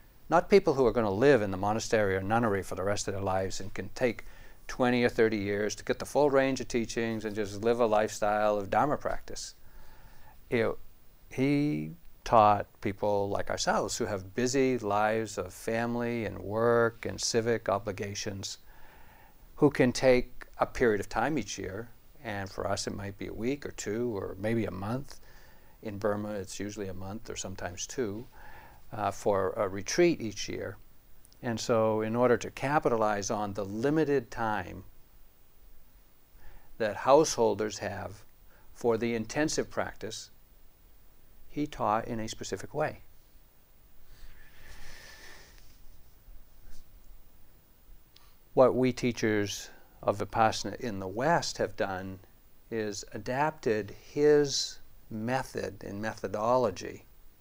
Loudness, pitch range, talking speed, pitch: -30 LUFS, 100-120 Hz, 140 wpm, 110 Hz